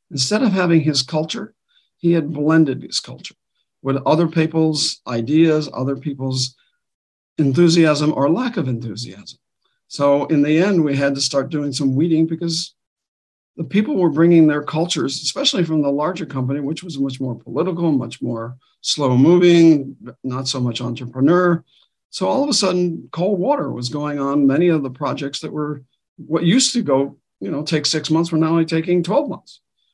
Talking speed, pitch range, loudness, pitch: 175 wpm, 140-170 Hz, -18 LUFS, 155 Hz